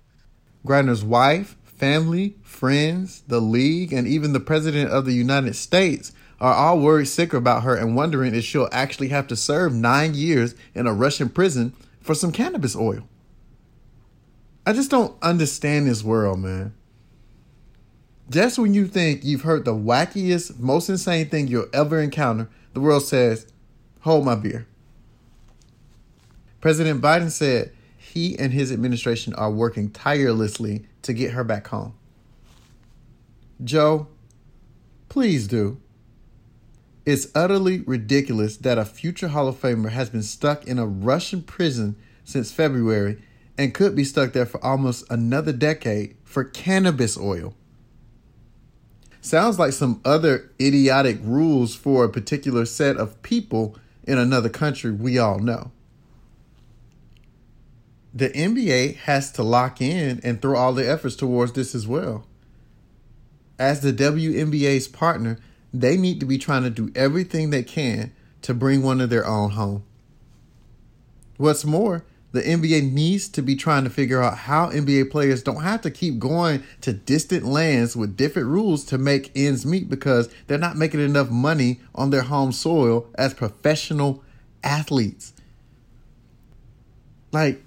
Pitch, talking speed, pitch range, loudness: 130 Hz, 145 wpm, 120-150 Hz, -21 LUFS